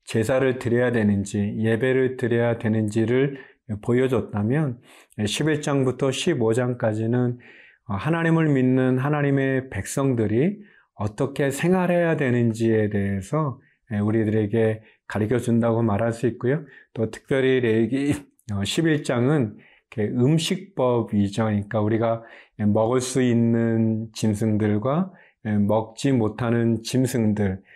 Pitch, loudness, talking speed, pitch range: 120 Hz, -23 LUFS, 240 characters per minute, 110-135 Hz